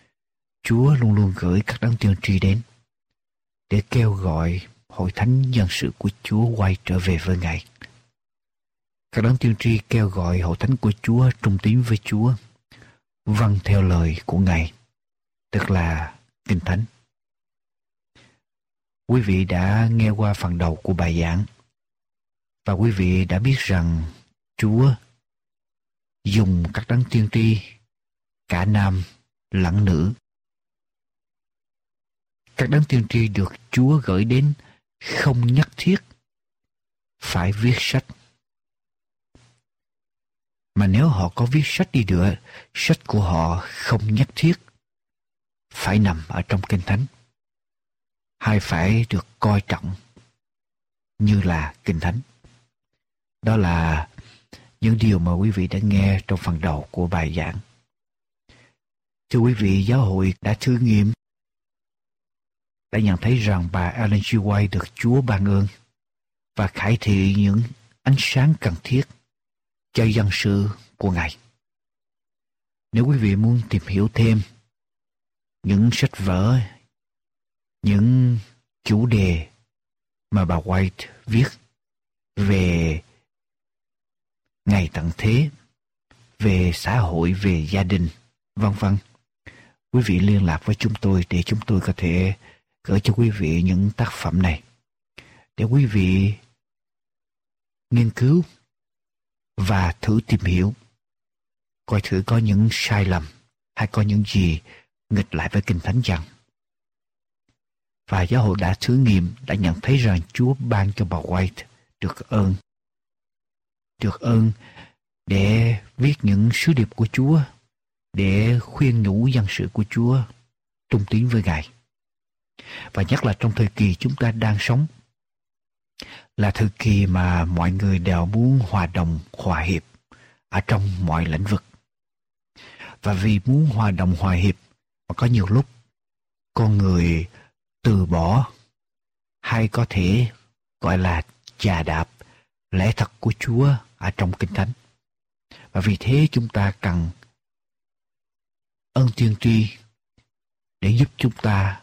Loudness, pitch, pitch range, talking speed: -21 LUFS, 105 Hz, 95-120 Hz, 135 wpm